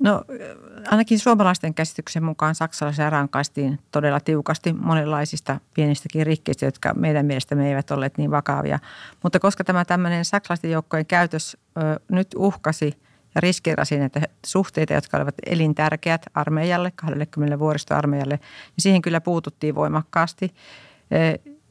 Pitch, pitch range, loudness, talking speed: 155 Hz, 145-175 Hz, -22 LUFS, 125 wpm